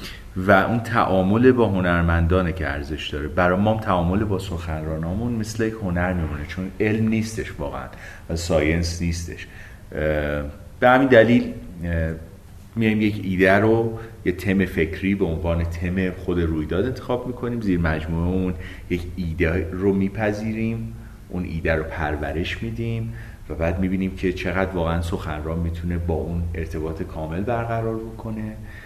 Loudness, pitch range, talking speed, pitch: -22 LUFS, 85-110 Hz, 140 wpm, 95 Hz